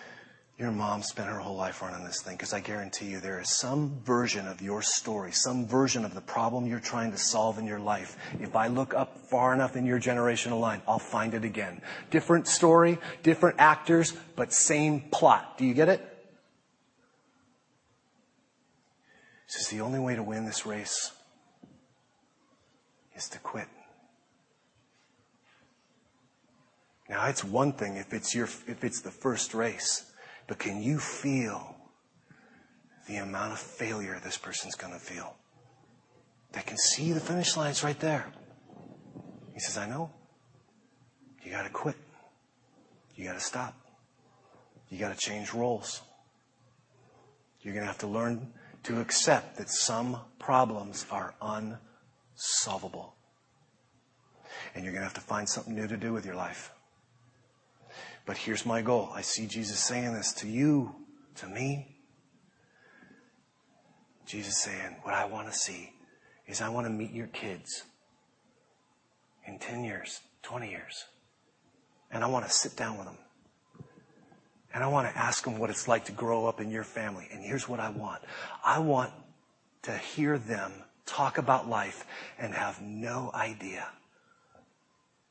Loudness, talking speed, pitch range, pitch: -30 LUFS, 150 wpm, 105-130 Hz, 115 Hz